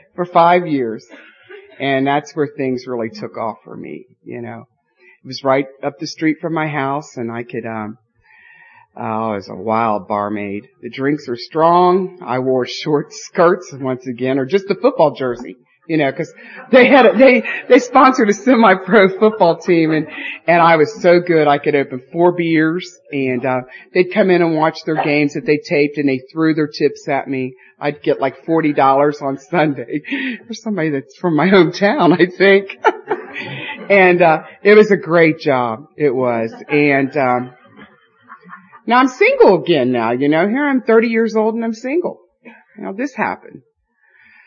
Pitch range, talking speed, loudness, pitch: 135-200 Hz, 180 wpm, -15 LUFS, 155 Hz